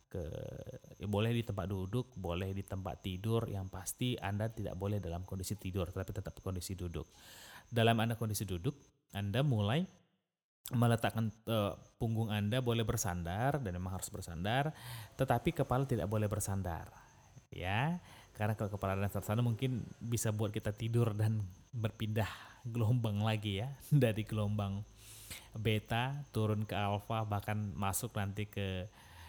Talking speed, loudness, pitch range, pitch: 140 wpm, -37 LUFS, 100-120 Hz, 110 Hz